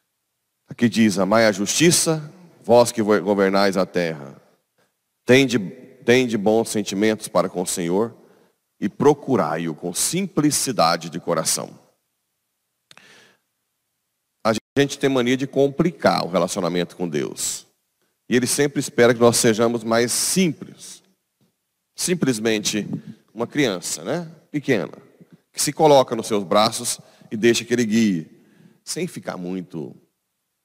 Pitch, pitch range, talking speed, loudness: 115 Hz, 100-140 Hz, 120 wpm, -20 LUFS